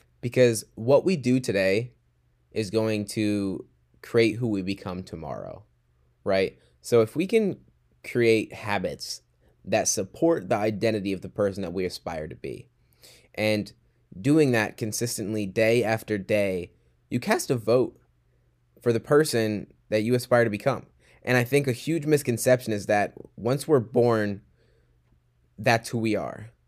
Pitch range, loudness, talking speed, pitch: 90-120 Hz, -25 LUFS, 150 wpm, 110 Hz